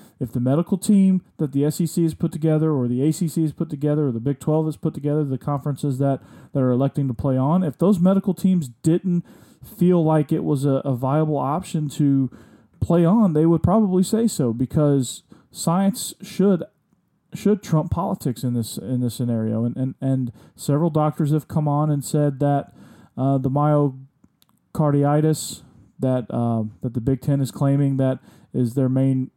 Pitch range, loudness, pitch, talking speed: 135-170 Hz, -21 LUFS, 150 Hz, 185 wpm